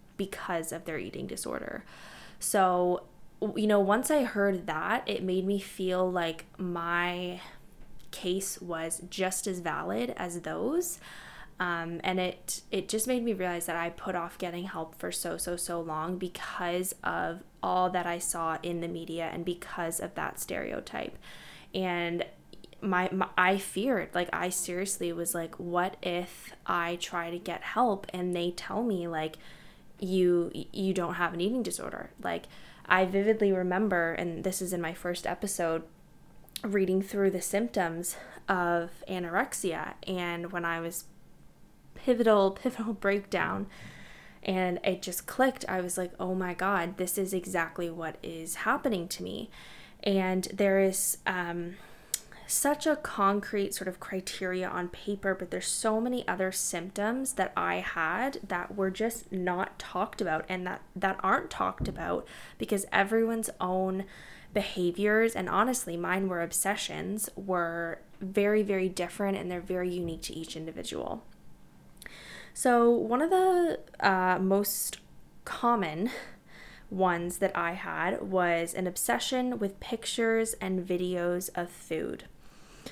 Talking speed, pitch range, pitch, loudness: 145 wpm, 175-200 Hz, 185 Hz, -31 LUFS